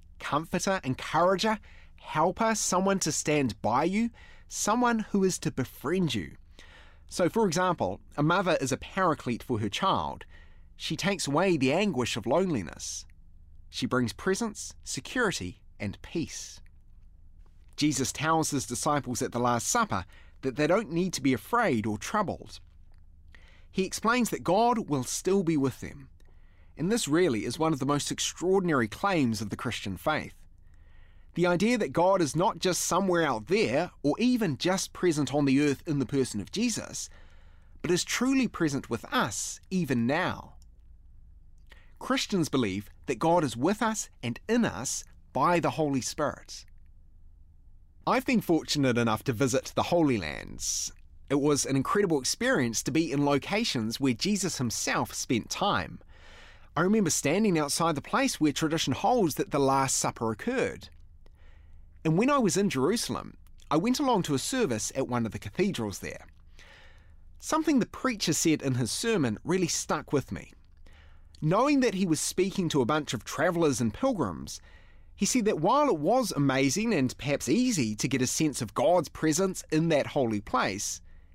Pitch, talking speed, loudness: 135 Hz, 165 wpm, -28 LUFS